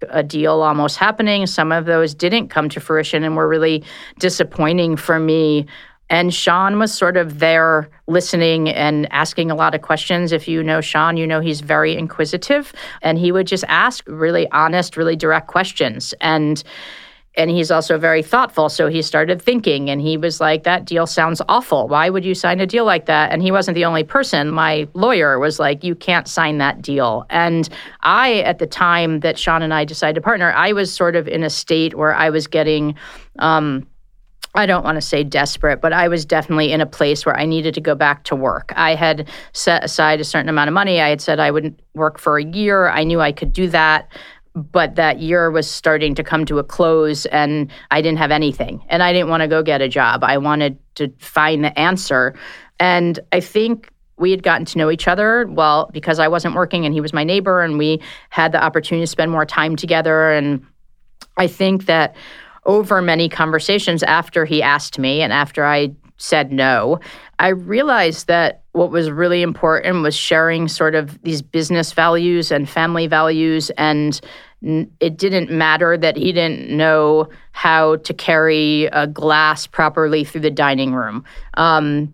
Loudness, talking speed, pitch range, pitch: -16 LUFS, 200 wpm, 155-175 Hz, 160 Hz